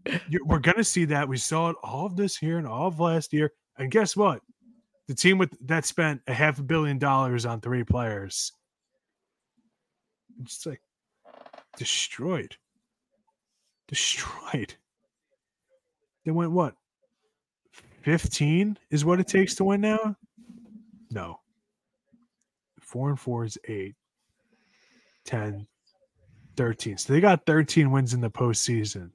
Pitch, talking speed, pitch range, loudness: 160 Hz, 135 wpm, 130-215 Hz, -26 LUFS